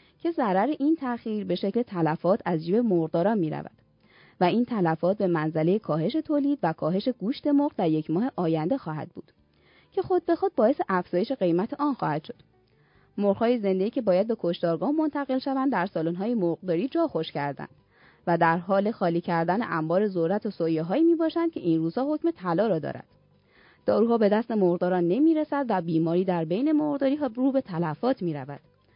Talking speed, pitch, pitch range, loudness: 175 wpm, 195 Hz, 170-270 Hz, -26 LUFS